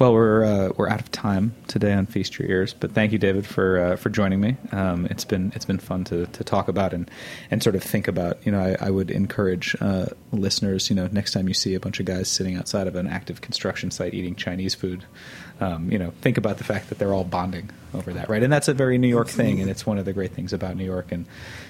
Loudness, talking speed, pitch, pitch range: -24 LUFS, 270 wpm, 95 Hz, 95-110 Hz